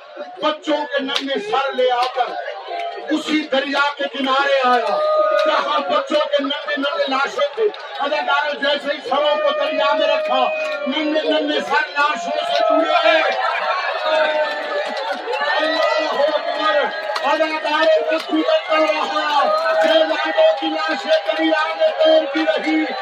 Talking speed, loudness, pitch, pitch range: 95 wpm, -18 LUFS, 295 Hz, 270-310 Hz